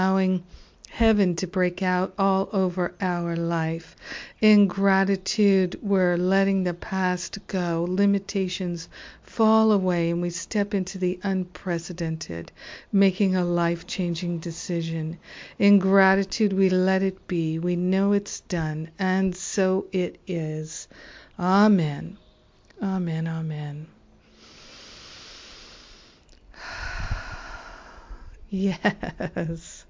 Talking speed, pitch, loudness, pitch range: 95 wpm, 185 Hz, -24 LUFS, 170-195 Hz